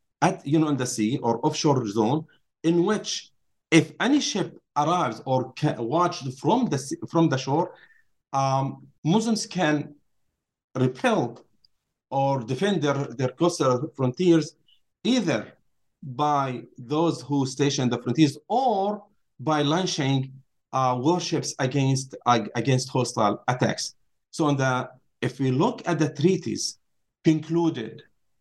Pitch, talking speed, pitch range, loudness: 145 Hz, 125 wpm, 130-165 Hz, -25 LUFS